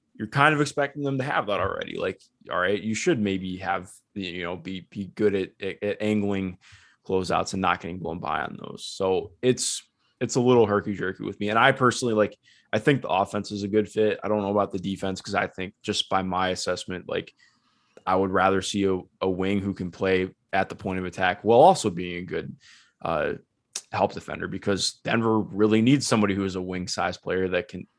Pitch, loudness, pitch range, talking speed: 100 Hz, -25 LUFS, 95-110 Hz, 220 wpm